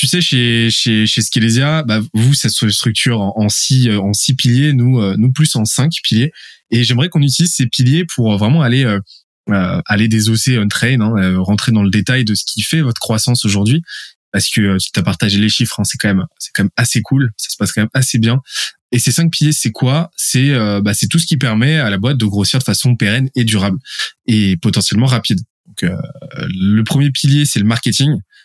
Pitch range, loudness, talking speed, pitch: 105-135 Hz, -13 LUFS, 225 wpm, 120 Hz